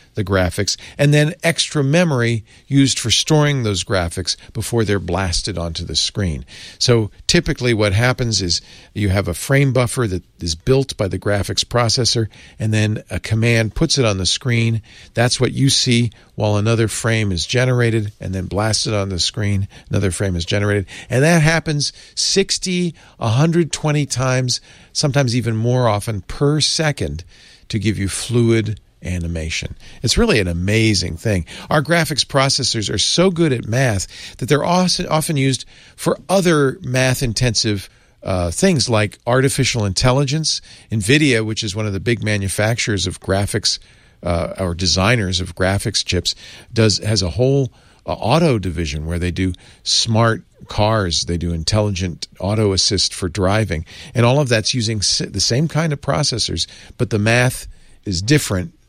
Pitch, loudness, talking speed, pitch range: 110 Hz, -17 LUFS, 155 wpm, 95-130 Hz